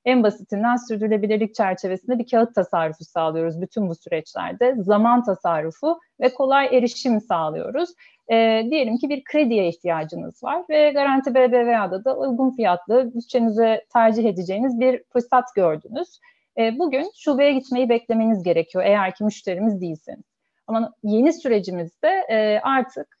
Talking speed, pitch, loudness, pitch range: 130 wpm, 230 Hz, -21 LUFS, 205-265 Hz